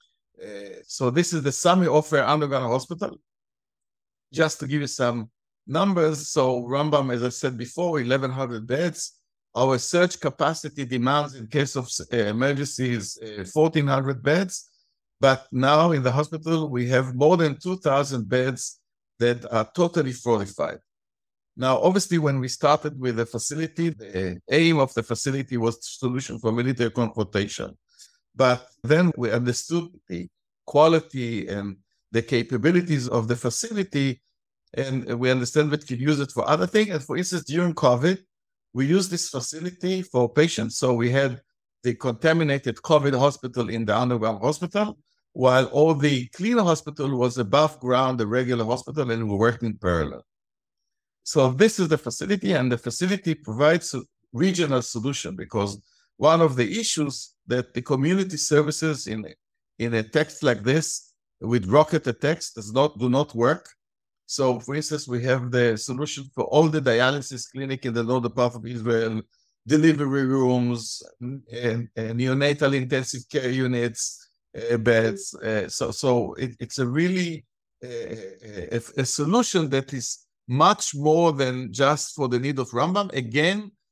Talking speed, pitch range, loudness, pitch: 155 wpm, 120-155 Hz, -23 LUFS, 135 Hz